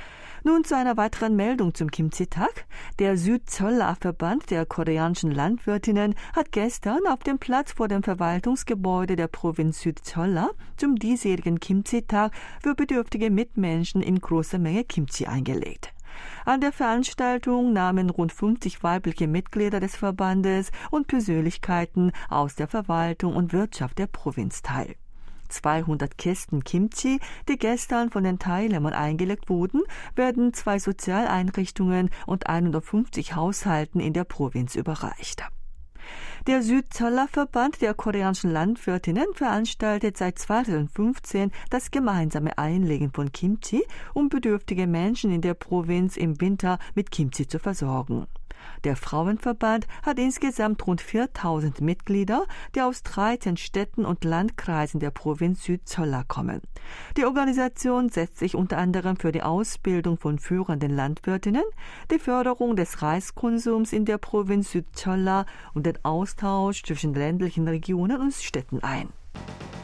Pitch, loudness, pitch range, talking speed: 190 Hz, -26 LUFS, 165-230 Hz, 125 wpm